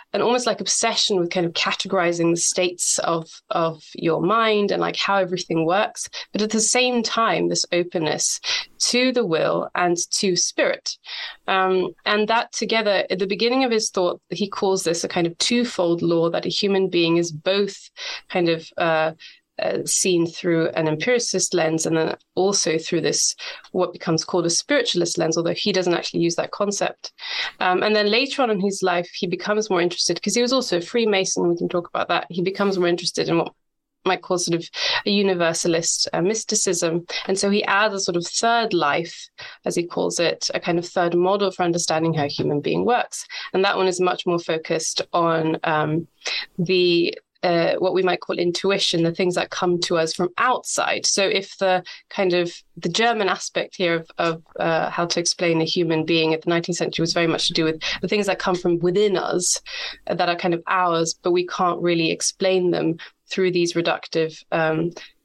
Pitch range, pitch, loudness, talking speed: 170-200 Hz, 180 Hz, -21 LUFS, 200 wpm